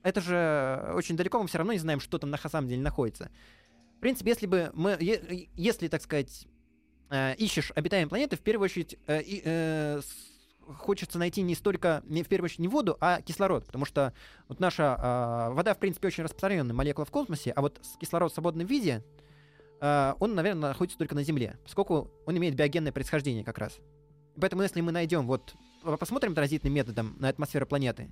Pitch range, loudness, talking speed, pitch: 145-180 Hz, -30 LUFS, 190 wpm, 155 Hz